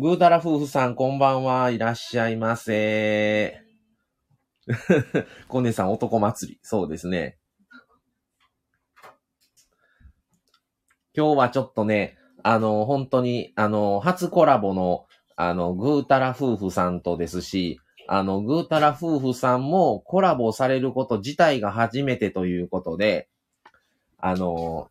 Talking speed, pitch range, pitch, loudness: 255 characters per minute, 100-140 Hz, 115 Hz, -23 LUFS